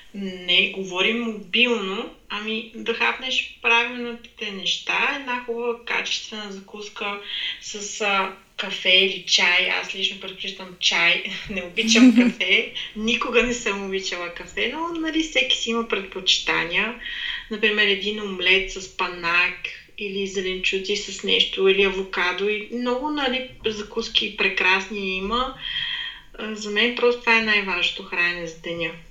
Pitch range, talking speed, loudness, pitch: 190-235 Hz, 130 wpm, -21 LUFS, 205 Hz